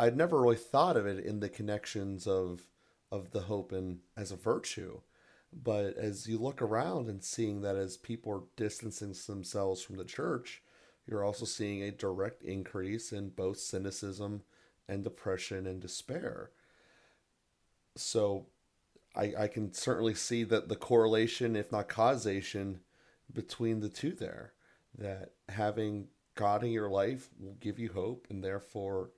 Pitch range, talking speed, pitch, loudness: 95-110 Hz, 150 wpm, 100 Hz, -36 LUFS